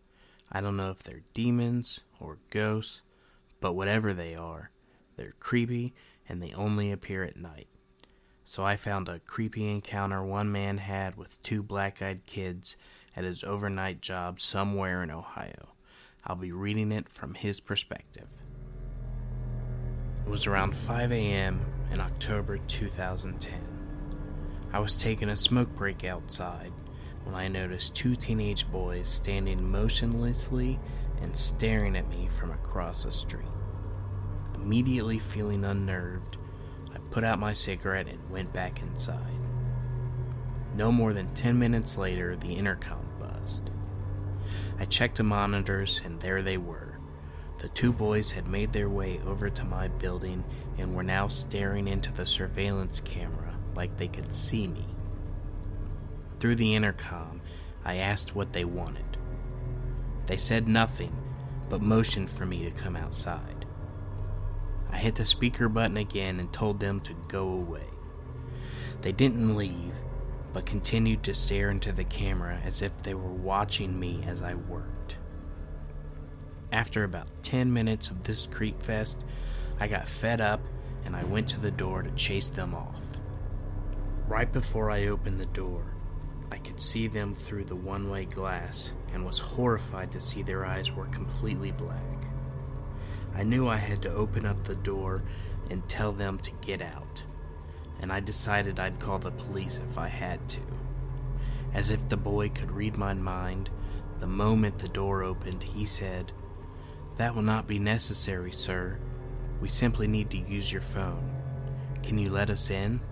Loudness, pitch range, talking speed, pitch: -31 LUFS, 90-110 Hz, 150 wpm, 100 Hz